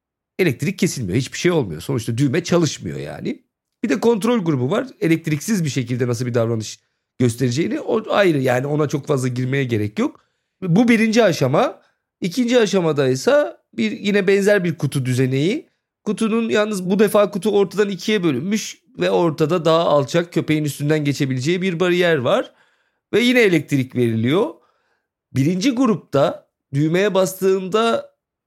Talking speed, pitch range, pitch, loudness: 145 wpm, 140-210 Hz, 170 Hz, -19 LUFS